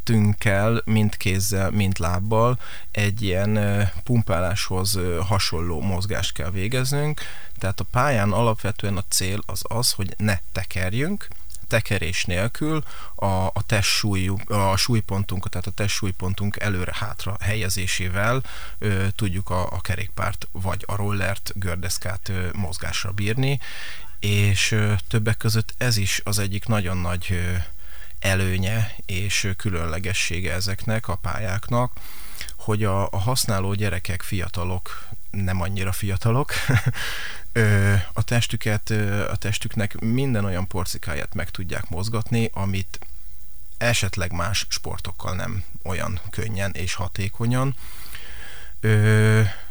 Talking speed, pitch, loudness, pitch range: 105 wpm, 100 Hz, -24 LUFS, 95-110 Hz